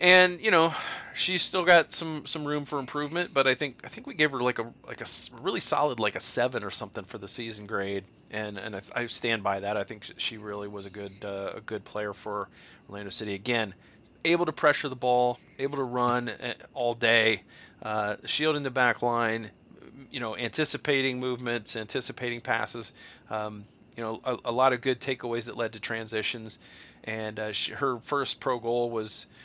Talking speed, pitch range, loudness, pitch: 200 wpm, 110-135 Hz, -28 LUFS, 120 Hz